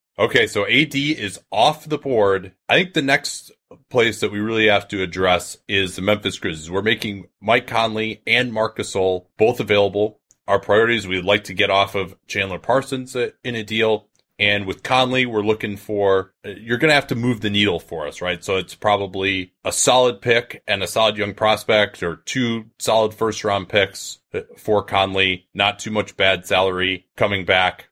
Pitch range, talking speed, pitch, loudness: 95-115 Hz, 185 wpm, 105 Hz, -19 LUFS